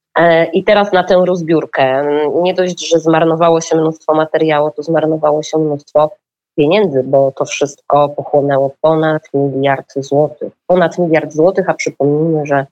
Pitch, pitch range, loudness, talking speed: 155 Hz, 145-165 Hz, -13 LUFS, 140 wpm